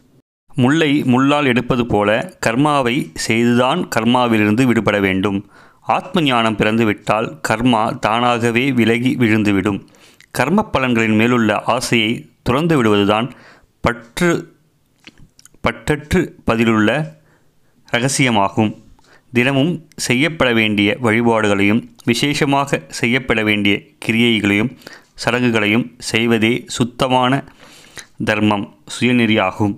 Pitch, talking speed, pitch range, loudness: 120 Hz, 80 wpm, 110-130 Hz, -16 LUFS